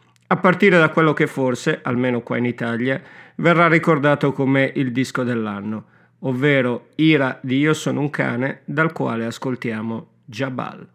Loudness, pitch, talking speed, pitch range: -19 LUFS, 135 Hz, 150 wpm, 120-155 Hz